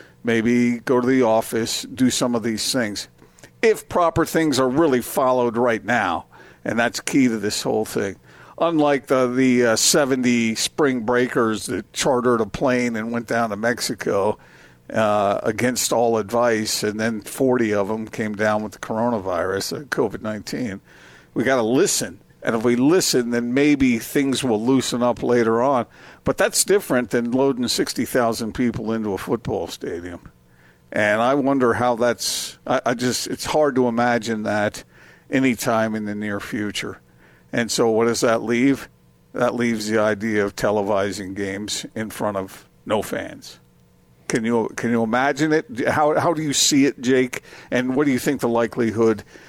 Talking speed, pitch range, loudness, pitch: 170 wpm, 110-125 Hz, -20 LUFS, 115 Hz